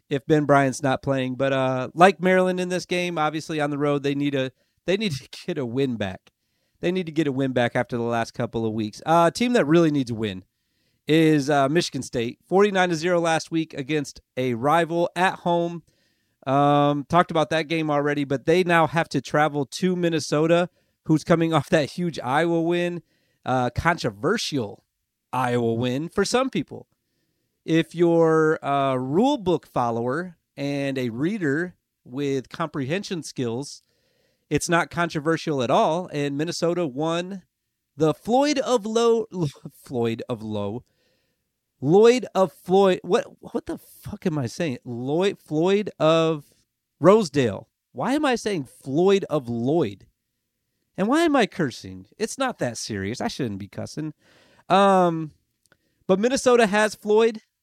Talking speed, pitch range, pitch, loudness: 160 wpm, 130-175 Hz, 155 Hz, -23 LUFS